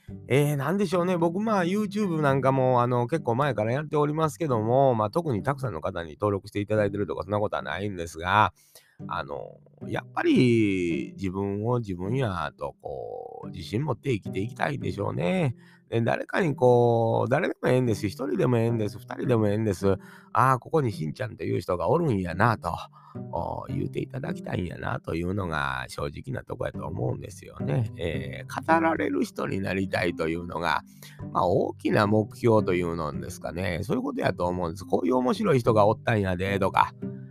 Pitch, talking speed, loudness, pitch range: 115 Hz, 410 characters per minute, -26 LUFS, 95-135 Hz